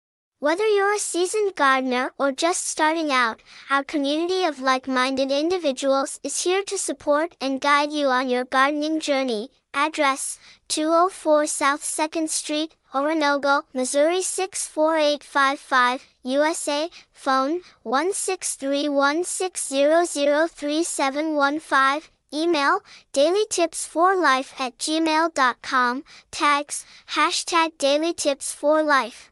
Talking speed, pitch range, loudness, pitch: 95 wpm, 275-330 Hz, -22 LUFS, 295 Hz